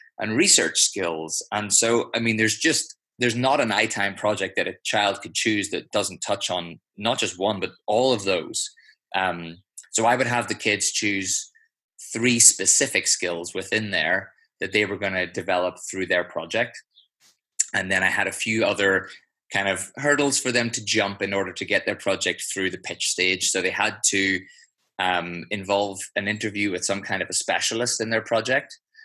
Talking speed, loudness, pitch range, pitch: 190 wpm, -22 LUFS, 95-115 Hz, 100 Hz